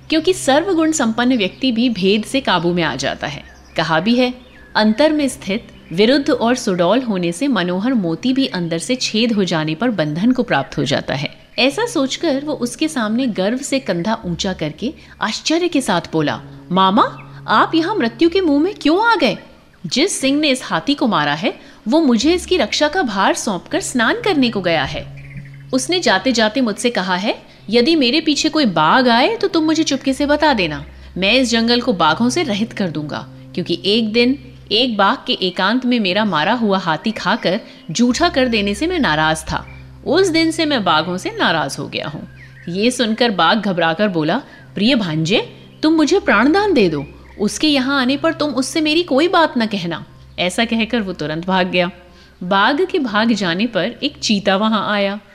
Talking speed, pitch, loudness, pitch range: 195 wpm, 235 Hz, -16 LUFS, 185-285 Hz